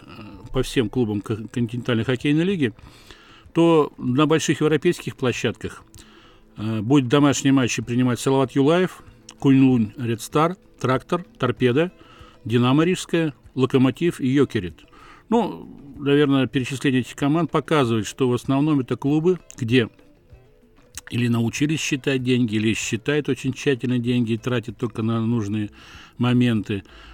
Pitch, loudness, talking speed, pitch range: 130 Hz, -21 LUFS, 120 wpm, 115-145 Hz